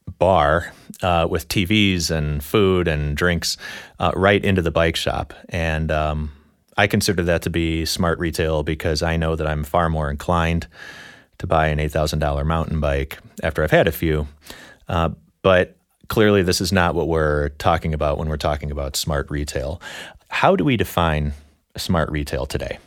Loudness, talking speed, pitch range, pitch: -20 LUFS, 170 wpm, 75-85 Hz, 80 Hz